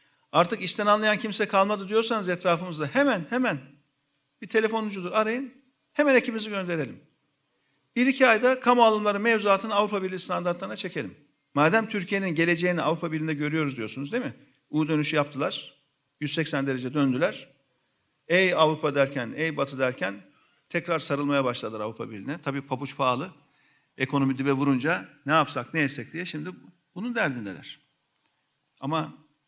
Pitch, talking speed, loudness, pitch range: 160 Hz, 135 wpm, -26 LUFS, 140-205 Hz